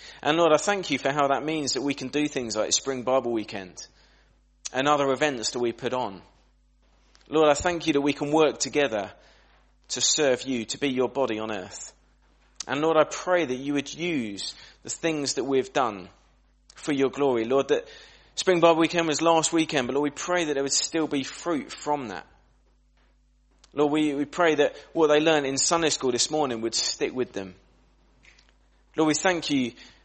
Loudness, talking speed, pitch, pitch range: -25 LUFS, 200 wpm, 145 Hz, 130-155 Hz